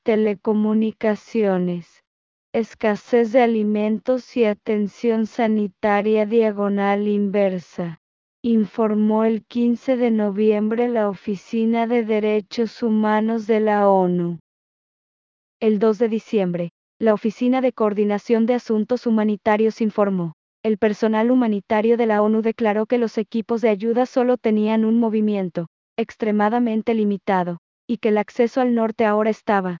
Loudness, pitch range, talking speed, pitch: -20 LUFS, 210-230 Hz, 120 wpm, 220 Hz